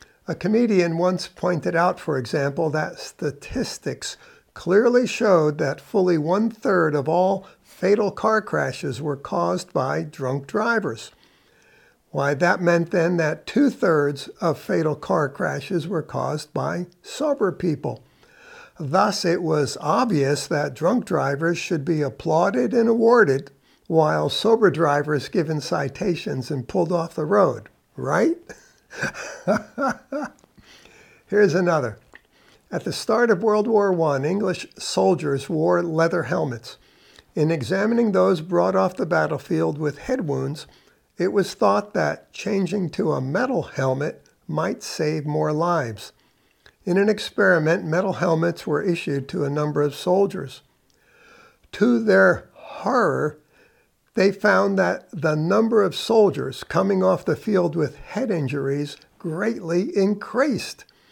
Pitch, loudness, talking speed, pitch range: 175 Hz, -22 LUFS, 130 wpm, 150-200 Hz